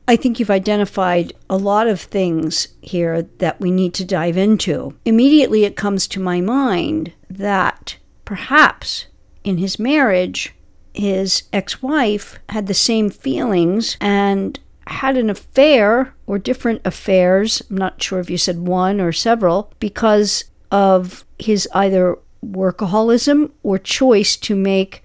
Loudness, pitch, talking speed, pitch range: -16 LUFS, 200 Hz, 140 wpm, 185-225 Hz